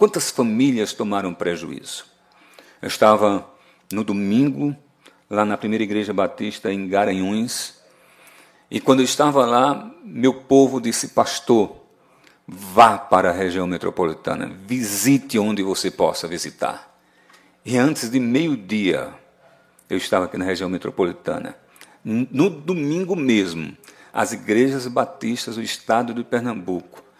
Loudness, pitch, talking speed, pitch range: -20 LUFS, 115 Hz, 120 wpm, 100-135 Hz